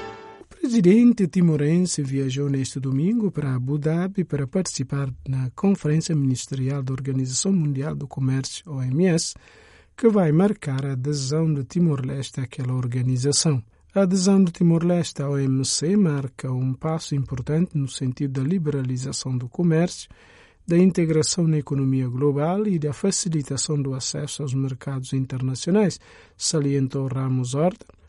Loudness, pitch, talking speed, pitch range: -23 LUFS, 145 Hz, 130 wpm, 135-175 Hz